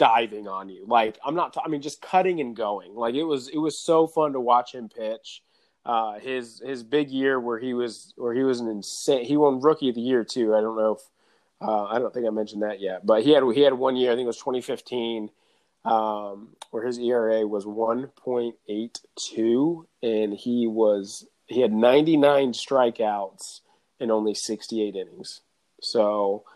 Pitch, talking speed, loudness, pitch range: 120 Hz, 210 wpm, -24 LUFS, 110-130 Hz